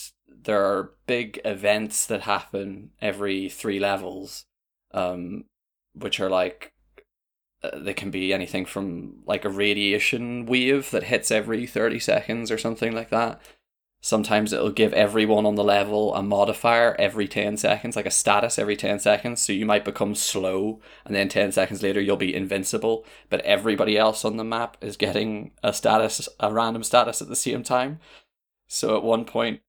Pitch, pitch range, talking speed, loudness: 105 Hz, 100-115 Hz, 170 wpm, -23 LUFS